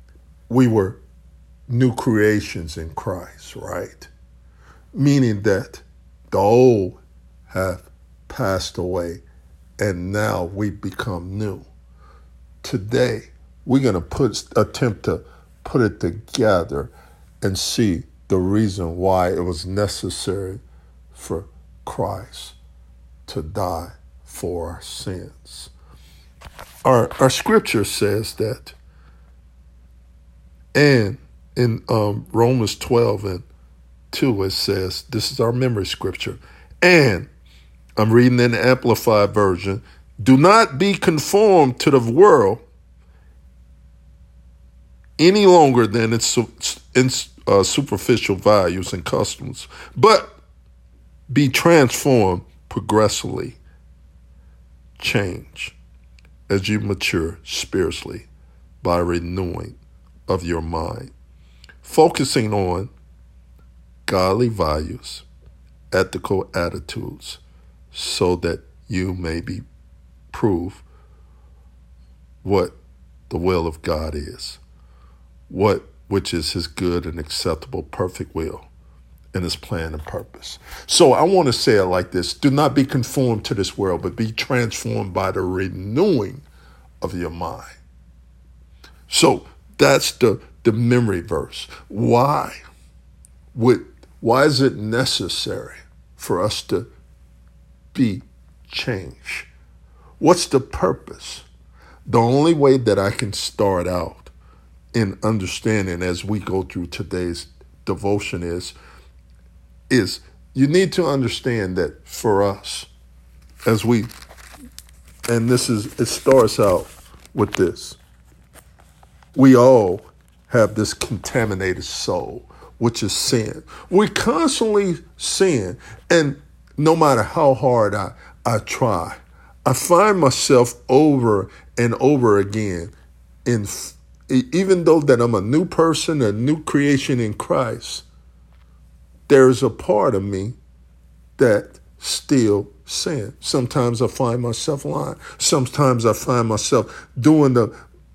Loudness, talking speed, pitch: -19 LUFS, 110 wpm, 85 Hz